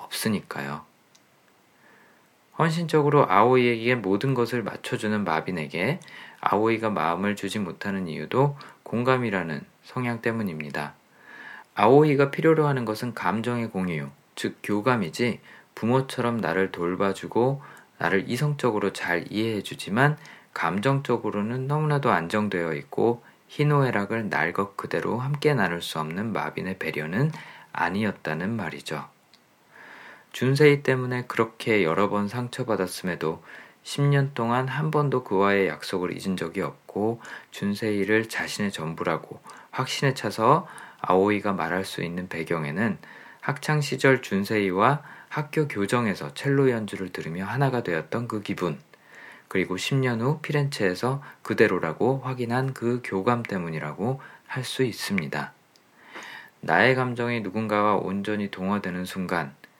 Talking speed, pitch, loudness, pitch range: 295 characters per minute, 115 Hz, -25 LUFS, 95-130 Hz